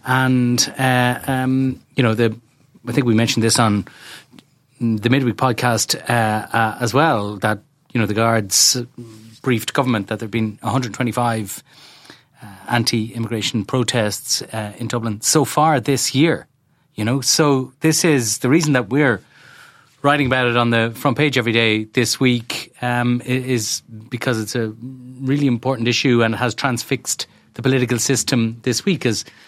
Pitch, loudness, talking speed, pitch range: 125 Hz, -18 LUFS, 160 wpm, 115-135 Hz